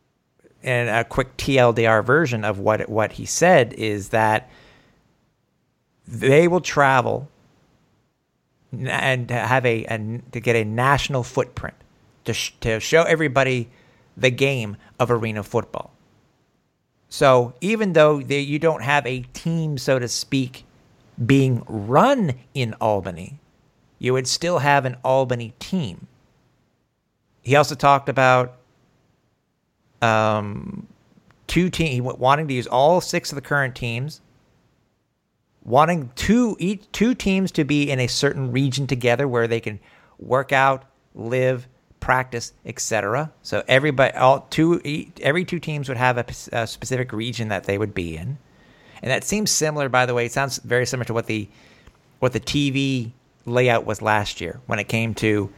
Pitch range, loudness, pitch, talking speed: 115-140 Hz, -20 LUFS, 130 Hz, 145 wpm